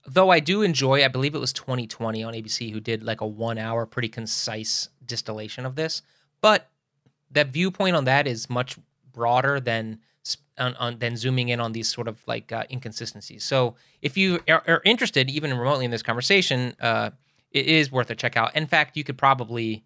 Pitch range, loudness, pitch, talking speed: 115-145 Hz, -24 LUFS, 125 Hz, 195 wpm